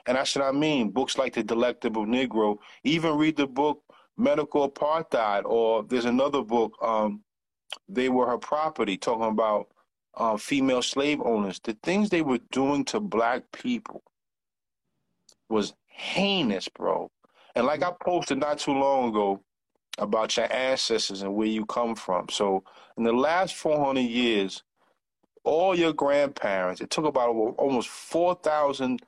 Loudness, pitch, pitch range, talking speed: -26 LUFS, 130 Hz, 115-155 Hz, 150 wpm